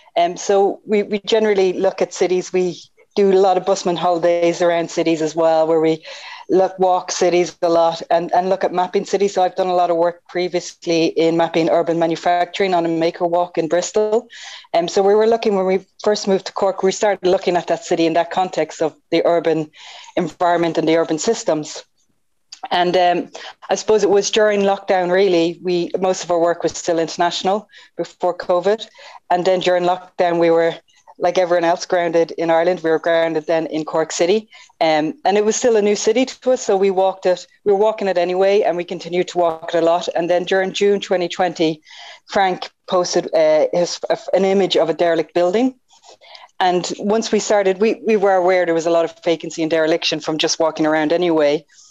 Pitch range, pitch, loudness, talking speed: 165-195 Hz, 180 Hz, -17 LUFS, 210 wpm